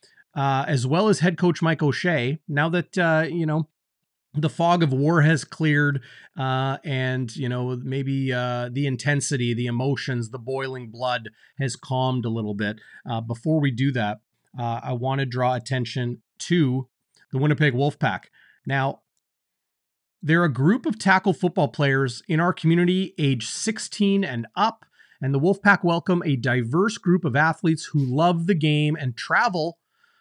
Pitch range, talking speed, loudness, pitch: 130-170 Hz, 165 wpm, -23 LUFS, 145 Hz